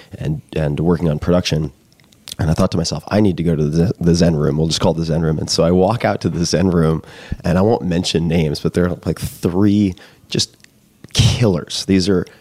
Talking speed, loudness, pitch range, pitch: 230 wpm, -17 LUFS, 80-95 Hz, 85 Hz